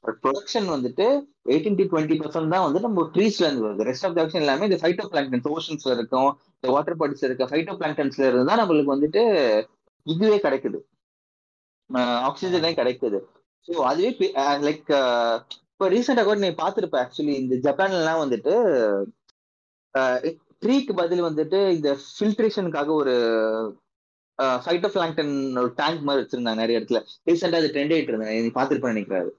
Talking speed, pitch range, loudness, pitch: 120 wpm, 130-180 Hz, -23 LUFS, 150 Hz